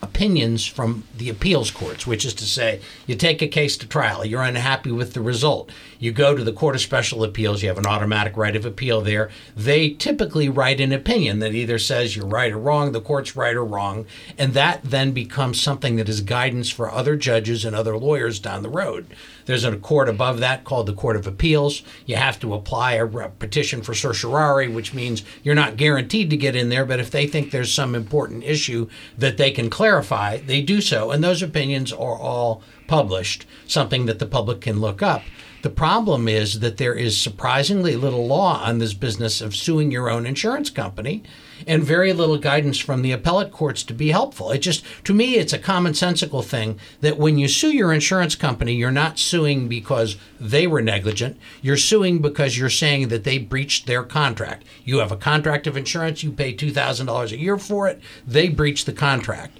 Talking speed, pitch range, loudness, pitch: 205 wpm, 115-150 Hz, -20 LUFS, 130 Hz